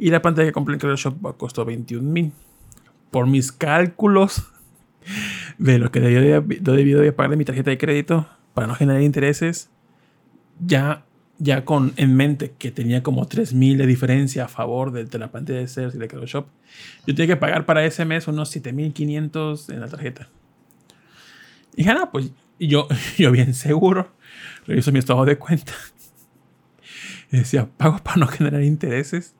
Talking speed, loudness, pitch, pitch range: 165 wpm, -20 LUFS, 145 Hz, 130-155 Hz